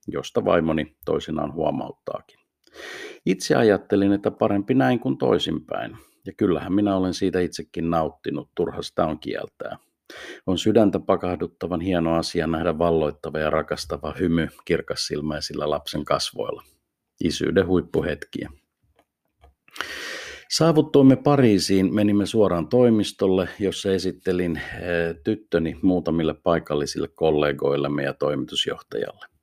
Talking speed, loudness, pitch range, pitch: 105 wpm, -23 LUFS, 80-110 Hz, 95 Hz